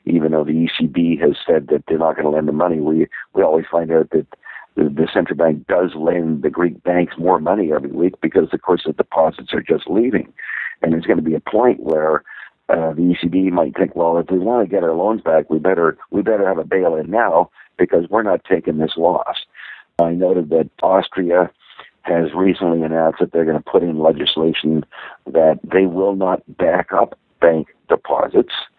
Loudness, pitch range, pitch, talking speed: -17 LUFS, 80-90 Hz, 85 Hz, 210 wpm